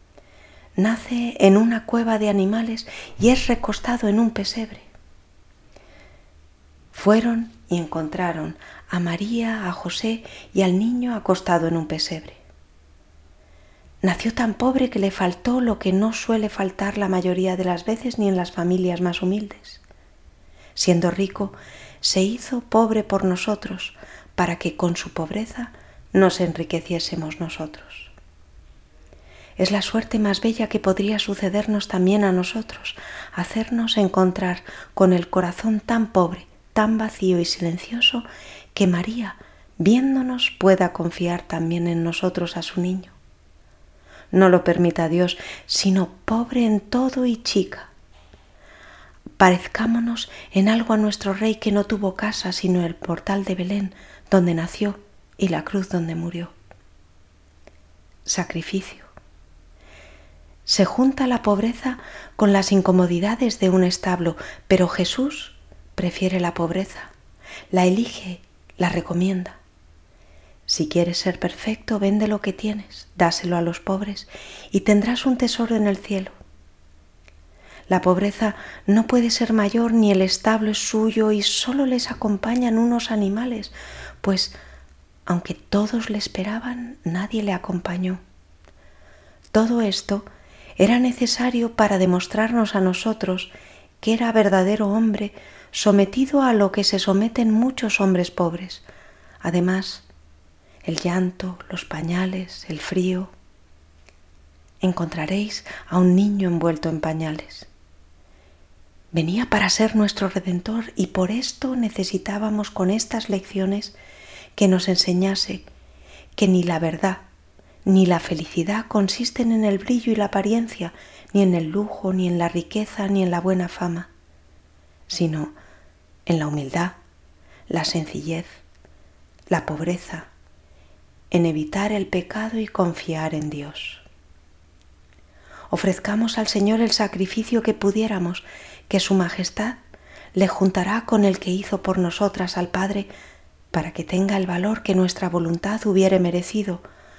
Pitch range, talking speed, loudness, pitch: 165-215 Hz, 130 wpm, -22 LUFS, 185 Hz